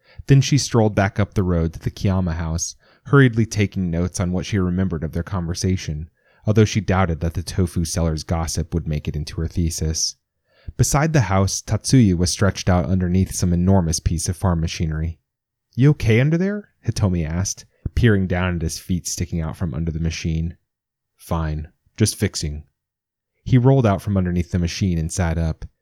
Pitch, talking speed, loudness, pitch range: 90 Hz, 180 wpm, -20 LUFS, 85-105 Hz